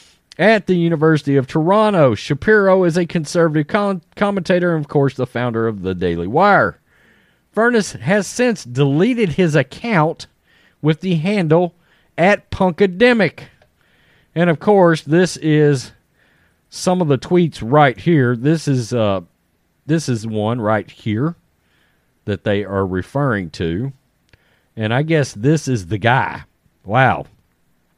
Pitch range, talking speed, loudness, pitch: 120-180 Hz, 135 wpm, -16 LUFS, 150 Hz